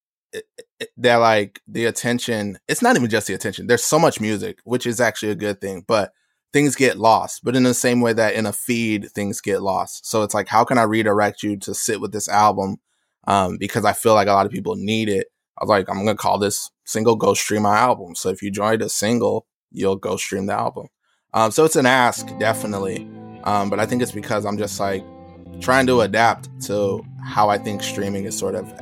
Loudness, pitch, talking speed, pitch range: -20 LUFS, 110 Hz, 230 wpm, 100-125 Hz